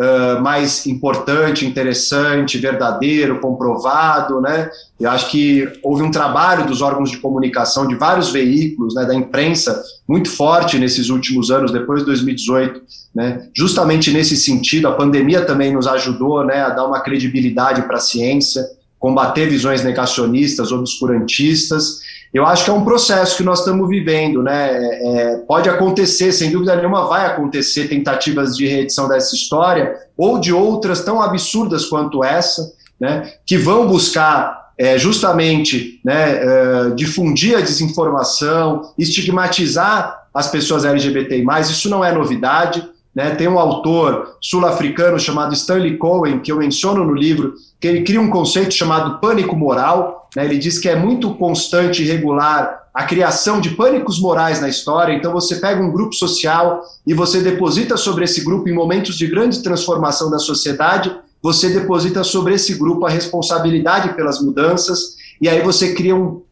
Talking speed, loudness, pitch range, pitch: 155 wpm, -15 LUFS, 140-180 Hz, 155 Hz